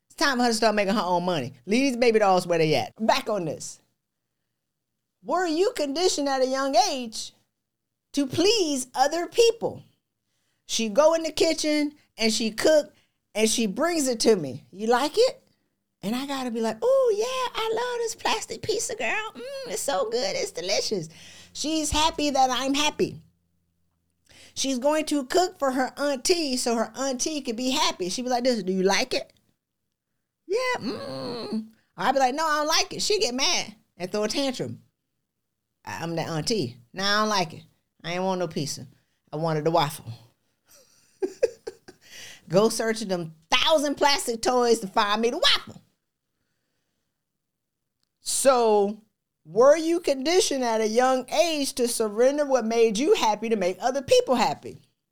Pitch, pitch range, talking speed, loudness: 250 Hz, 200-315 Hz, 170 wpm, -24 LUFS